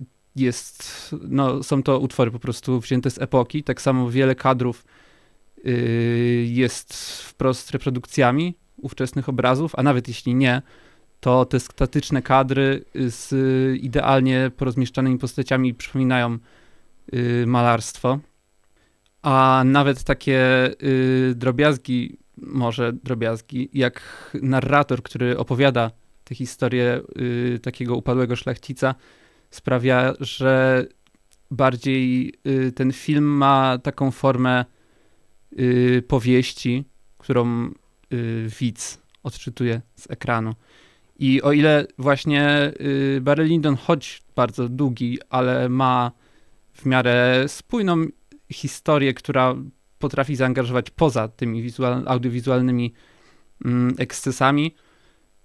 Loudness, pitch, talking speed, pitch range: -21 LUFS, 130 Hz, 95 wpm, 125-135 Hz